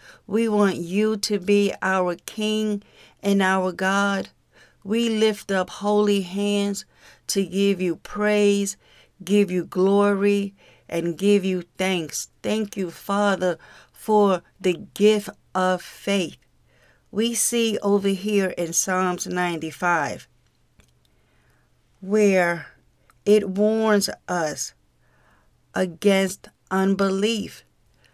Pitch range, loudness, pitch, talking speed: 185-210 Hz, -22 LUFS, 200 Hz, 100 wpm